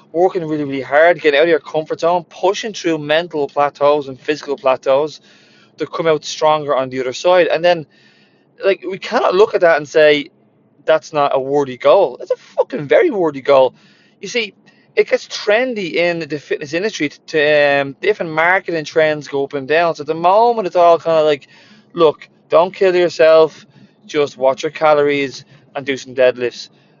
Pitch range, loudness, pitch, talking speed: 145-180 Hz, -15 LUFS, 155 Hz, 190 wpm